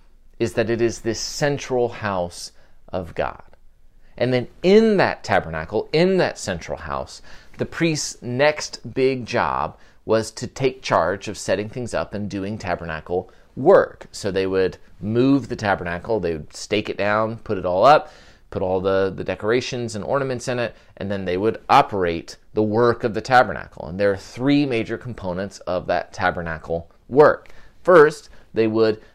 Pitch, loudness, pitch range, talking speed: 110 Hz, -21 LUFS, 95-125 Hz, 170 wpm